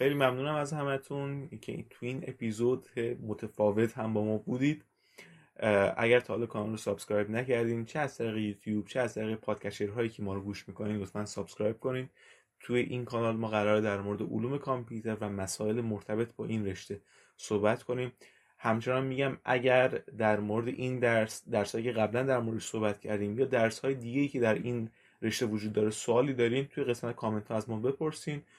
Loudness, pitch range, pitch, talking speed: -32 LUFS, 105-125 Hz, 115 Hz, 185 wpm